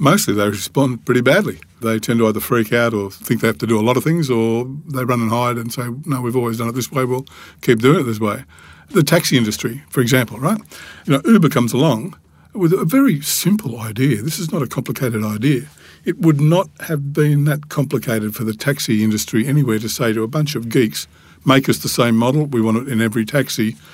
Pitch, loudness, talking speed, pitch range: 125 Hz, -17 LUFS, 235 wpm, 115-145 Hz